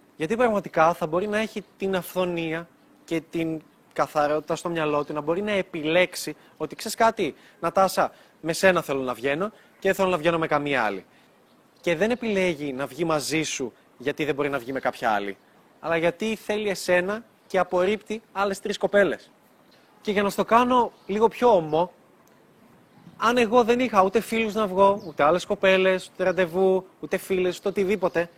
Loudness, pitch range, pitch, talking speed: -24 LUFS, 160-205 Hz, 185 Hz, 175 wpm